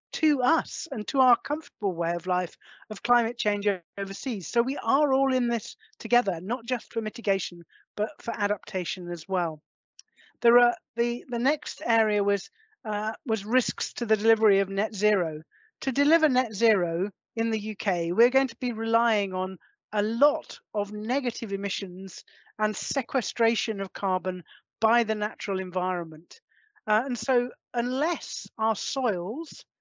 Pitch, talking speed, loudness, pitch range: 220 Hz, 155 wpm, -27 LUFS, 195-245 Hz